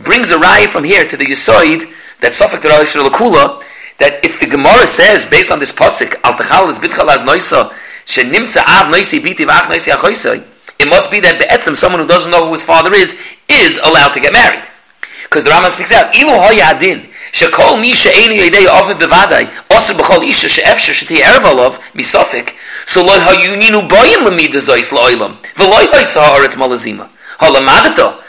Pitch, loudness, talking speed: 180 Hz, -6 LUFS, 200 wpm